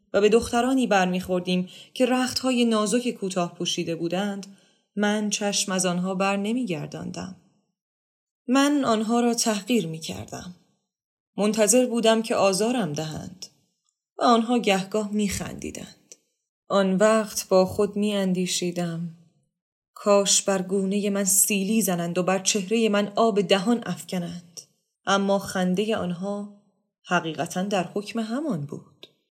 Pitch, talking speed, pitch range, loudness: 200 Hz, 115 wpm, 185-220 Hz, -23 LUFS